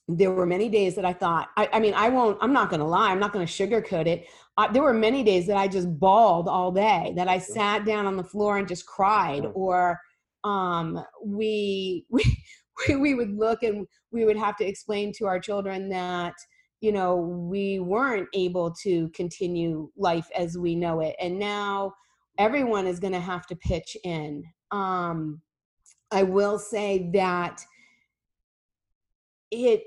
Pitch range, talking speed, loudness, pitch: 180-210 Hz, 175 wpm, -25 LUFS, 195 Hz